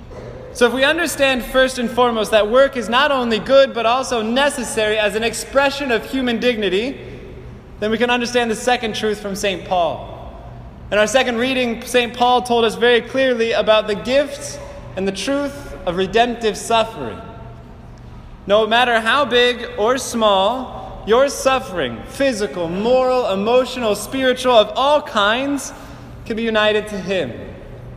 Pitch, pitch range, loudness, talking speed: 235 Hz, 215-255 Hz, -17 LUFS, 150 wpm